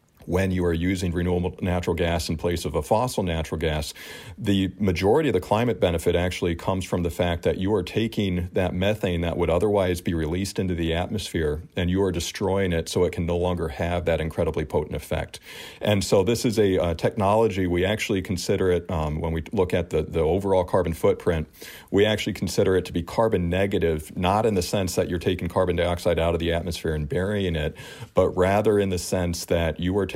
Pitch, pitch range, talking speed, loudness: 90 Hz, 85-95 Hz, 215 wpm, -24 LUFS